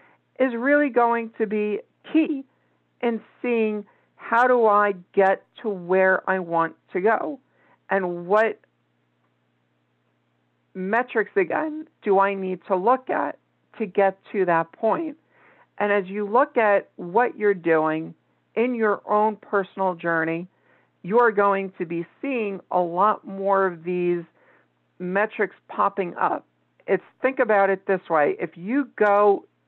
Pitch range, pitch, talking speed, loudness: 175-225 Hz, 200 Hz, 135 wpm, -23 LUFS